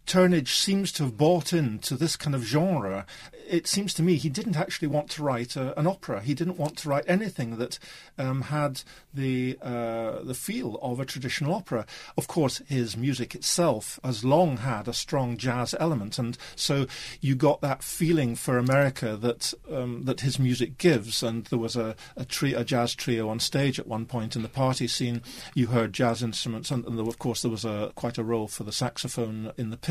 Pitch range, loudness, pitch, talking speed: 120-150 Hz, -28 LUFS, 130 Hz, 210 wpm